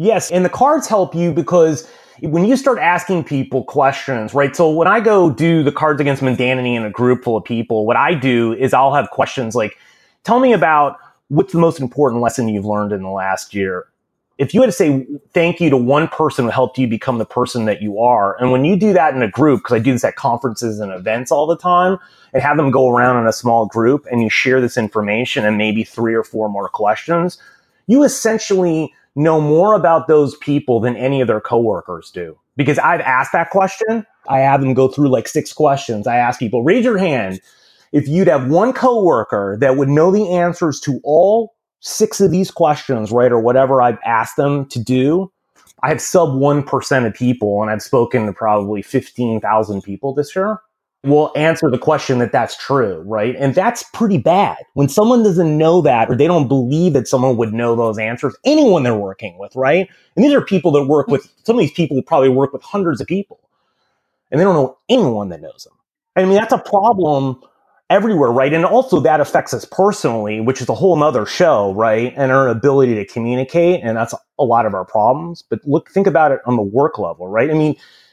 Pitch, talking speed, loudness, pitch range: 140 Hz, 215 wpm, -15 LUFS, 120-170 Hz